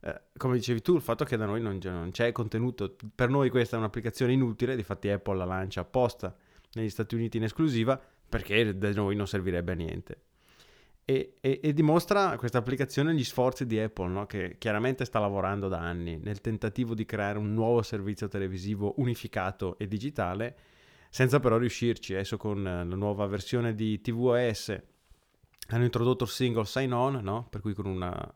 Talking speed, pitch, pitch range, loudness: 180 wpm, 115 Hz, 100-125 Hz, -30 LUFS